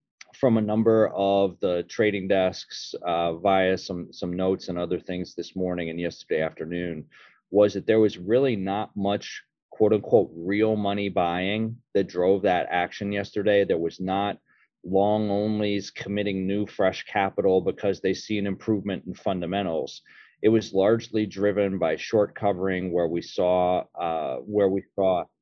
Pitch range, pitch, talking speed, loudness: 90-105 Hz, 100 Hz, 160 wpm, -25 LUFS